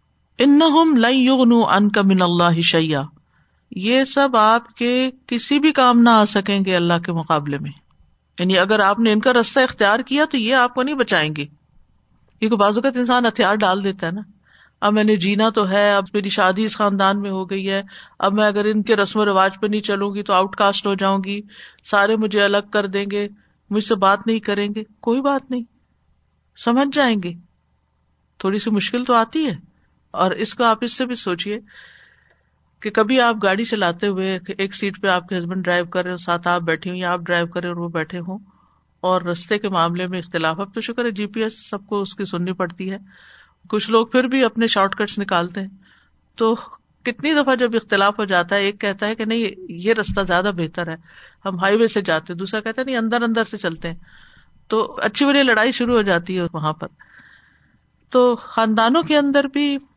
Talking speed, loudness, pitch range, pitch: 210 wpm, -18 LUFS, 185-230 Hz, 205 Hz